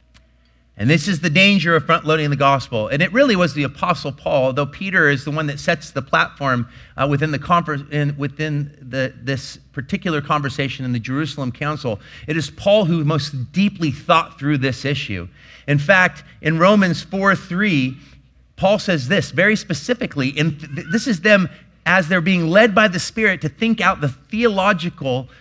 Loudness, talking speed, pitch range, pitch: -18 LUFS, 180 wpm, 135-185 Hz, 155 Hz